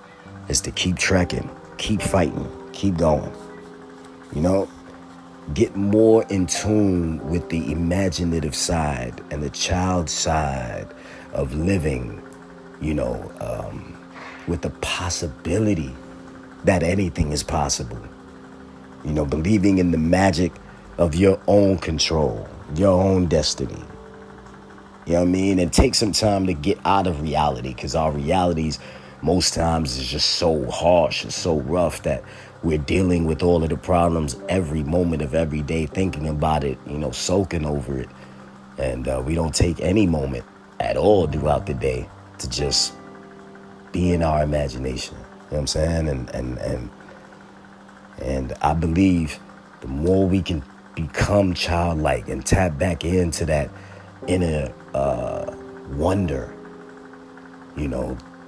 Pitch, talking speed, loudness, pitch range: 85 Hz, 145 wpm, -22 LUFS, 70-90 Hz